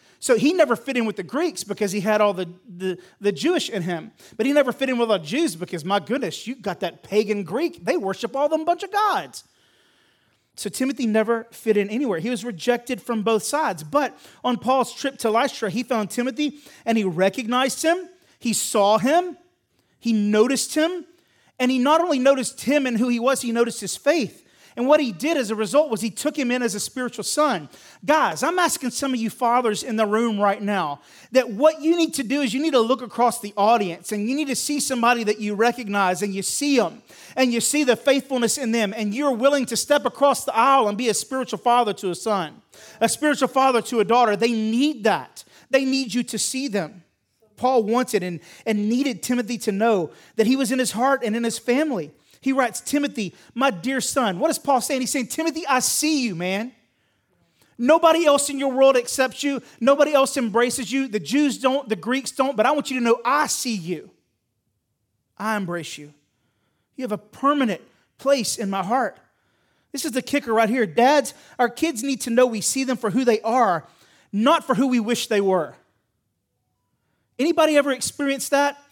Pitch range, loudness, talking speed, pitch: 215-275 Hz, -22 LUFS, 215 wpm, 245 Hz